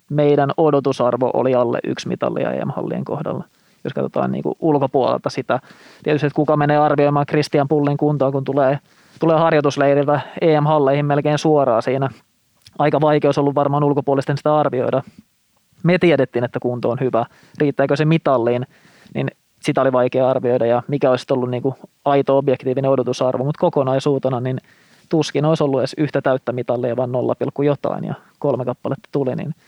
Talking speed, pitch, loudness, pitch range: 160 wpm, 140 Hz, -18 LUFS, 130-150 Hz